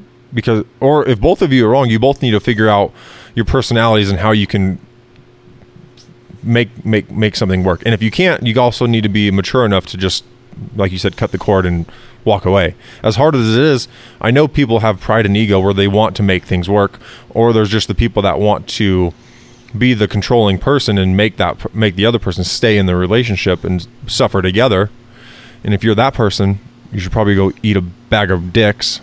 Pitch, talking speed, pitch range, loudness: 110 Hz, 220 wpm, 100-120 Hz, -13 LUFS